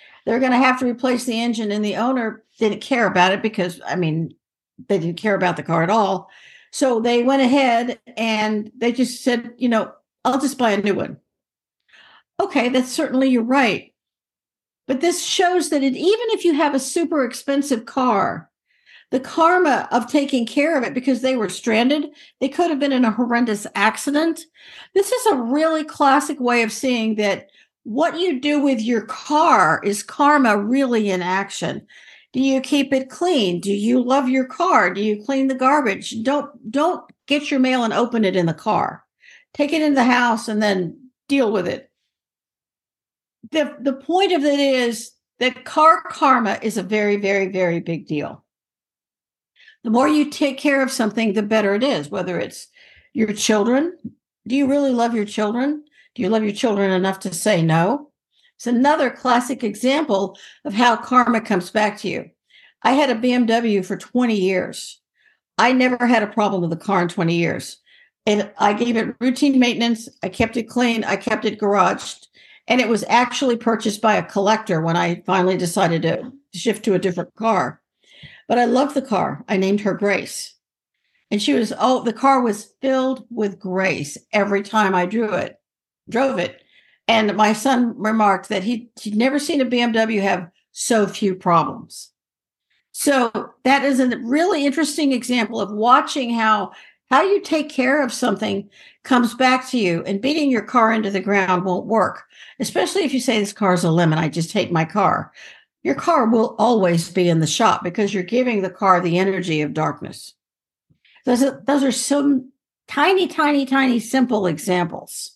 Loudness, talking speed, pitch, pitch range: -19 LUFS, 185 wpm, 235 Hz, 205-270 Hz